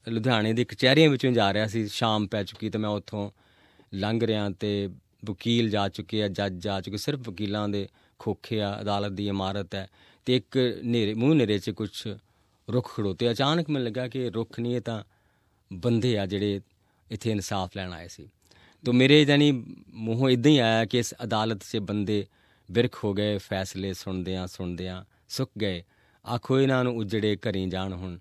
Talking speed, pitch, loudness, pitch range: 180 wpm, 105 Hz, -27 LUFS, 100-120 Hz